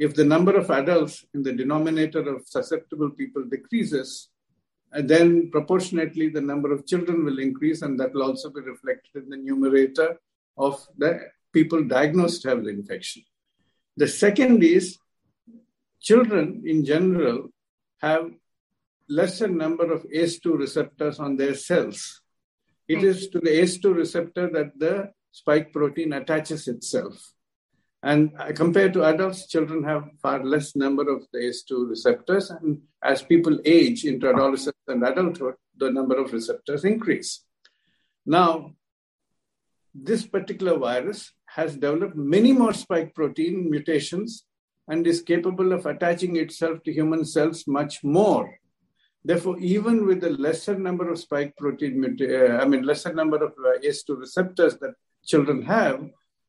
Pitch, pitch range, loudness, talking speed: 160 Hz, 145-180 Hz, -23 LUFS, 140 wpm